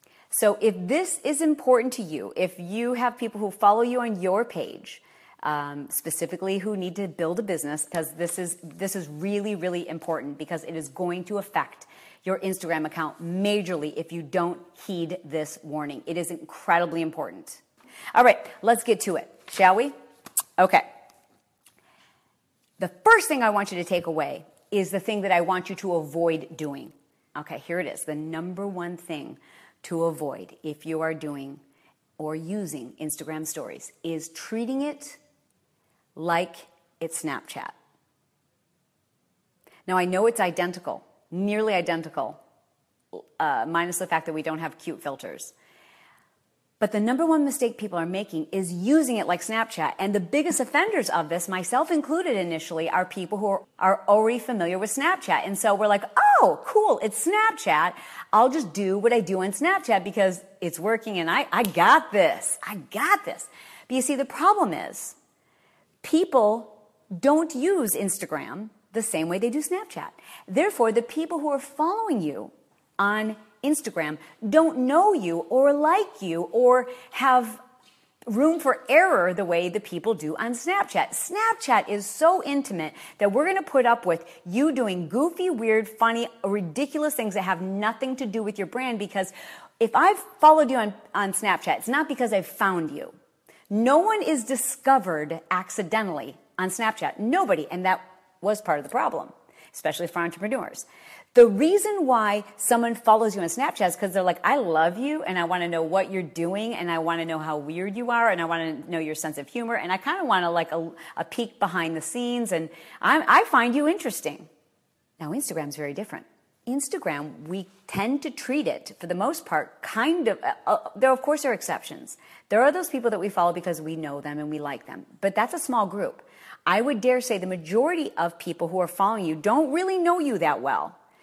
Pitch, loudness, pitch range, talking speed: 200 Hz, -25 LUFS, 170-255 Hz, 185 wpm